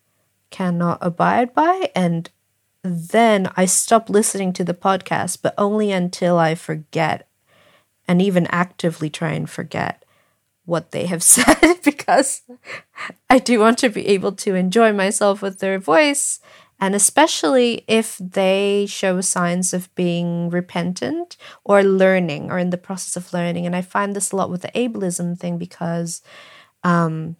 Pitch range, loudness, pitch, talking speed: 175-210 Hz, -18 LUFS, 185 Hz, 150 wpm